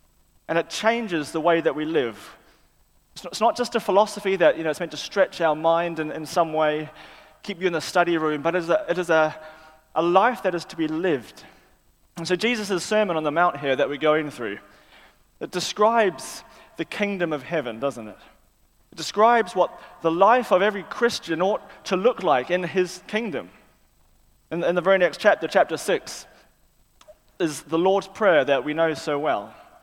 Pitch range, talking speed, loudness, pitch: 155-195 Hz, 200 wpm, -23 LUFS, 170 Hz